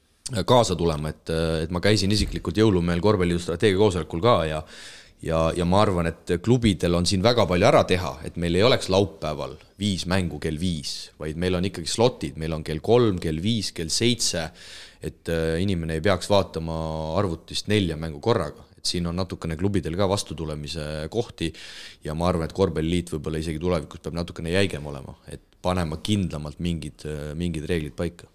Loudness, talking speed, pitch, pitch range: -24 LUFS, 175 wpm, 85 Hz, 80-95 Hz